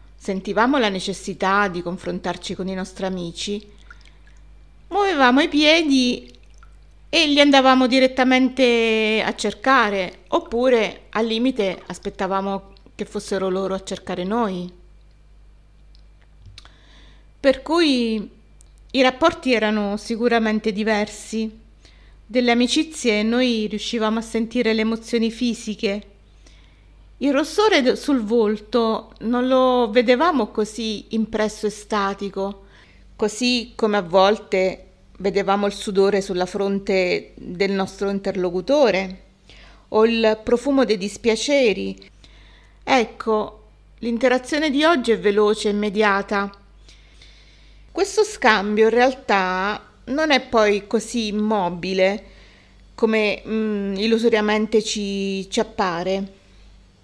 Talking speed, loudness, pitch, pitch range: 100 wpm, -20 LUFS, 215 Hz, 195-245 Hz